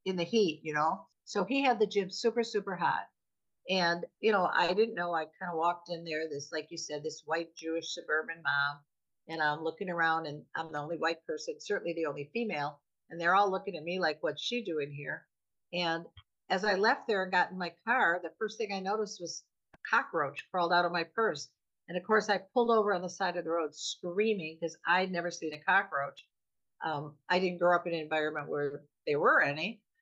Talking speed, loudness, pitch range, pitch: 225 wpm, -32 LUFS, 160-195 Hz, 170 Hz